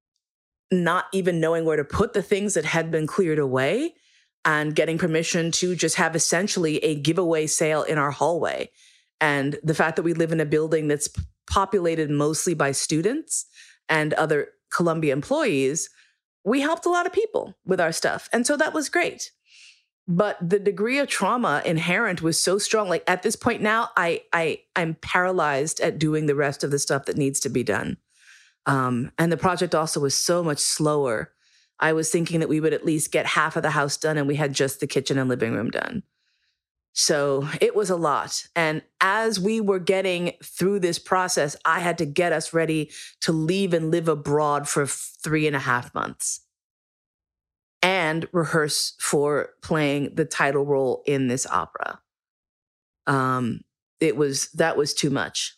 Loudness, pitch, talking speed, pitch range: -23 LUFS, 165 Hz, 180 wpm, 145-190 Hz